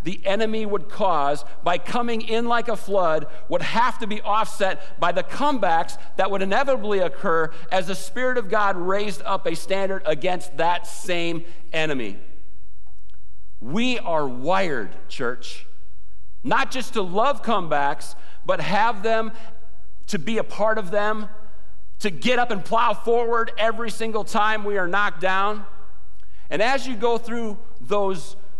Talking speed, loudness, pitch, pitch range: 150 wpm, -24 LUFS, 200 Hz, 170-225 Hz